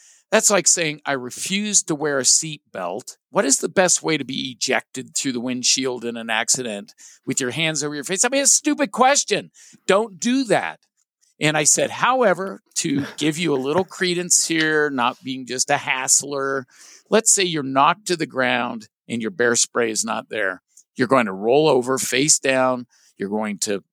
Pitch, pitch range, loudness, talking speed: 145 Hz, 125-180 Hz, -19 LUFS, 200 wpm